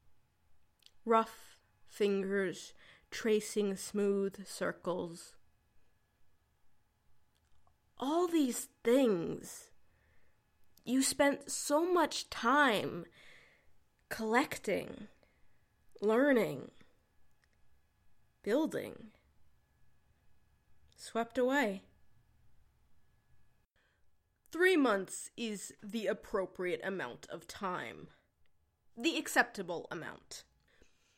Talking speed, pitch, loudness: 55 wpm, 205 Hz, -34 LUFS